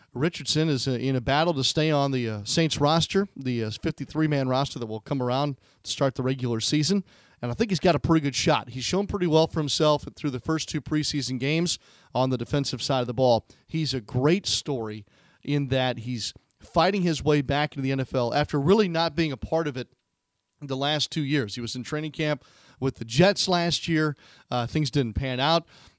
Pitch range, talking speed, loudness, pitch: 130-160 Hz, 215 wpm, -25 LUFS, 145 Hz